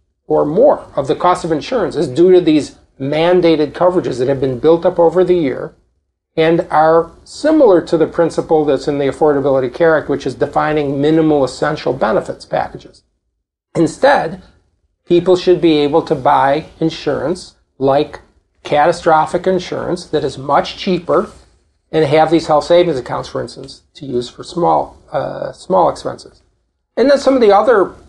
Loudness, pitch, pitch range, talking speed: -14 LUFS, 155 Hz, 140-175 Hz, 160 wpm